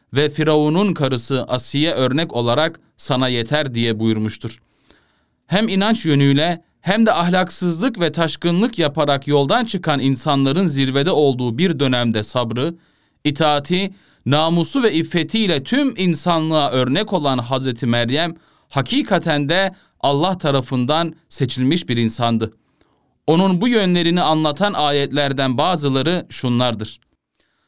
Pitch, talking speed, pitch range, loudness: 150 Hz, 110 wpm, 130-175 Hz, -18 LUFS